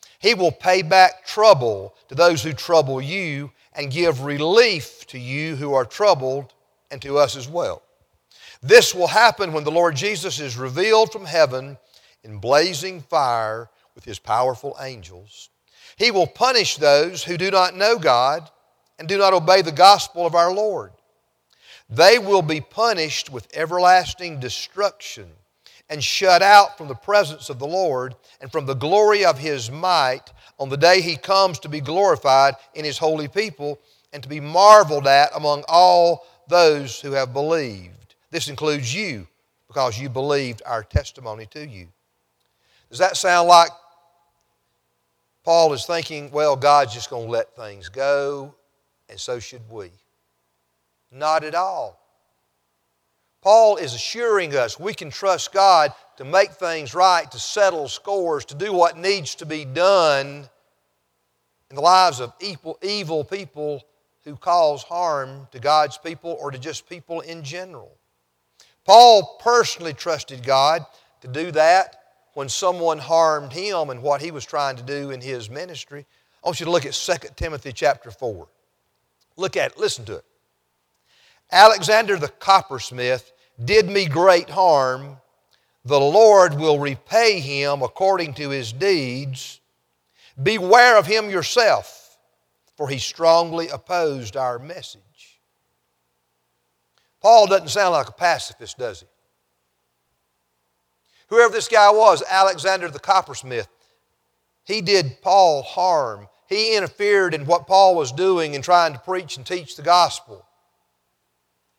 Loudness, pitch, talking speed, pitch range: -18 LUFS, 150 Hz, 145 wpm, 130-185 Hz